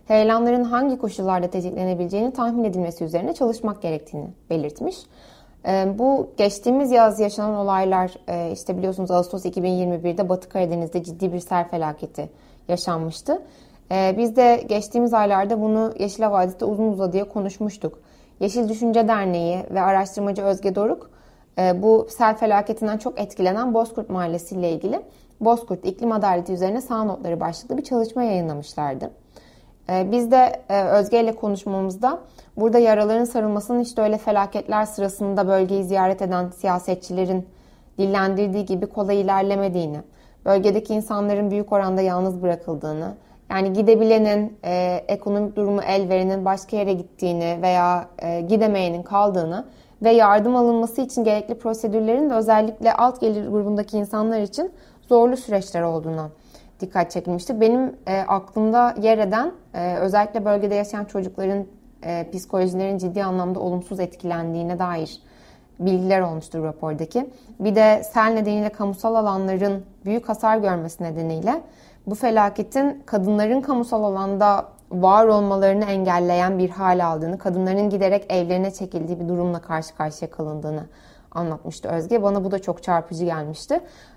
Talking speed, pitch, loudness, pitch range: 130 wpm, 200 Hz, -21 LUFS, 180-220 Hz